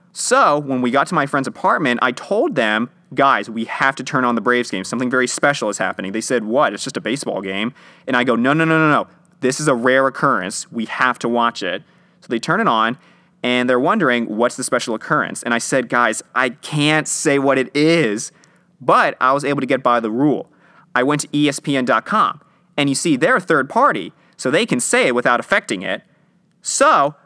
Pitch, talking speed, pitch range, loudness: 130 Hz, 225 wpm, 120-150 Hz, -17 LUFS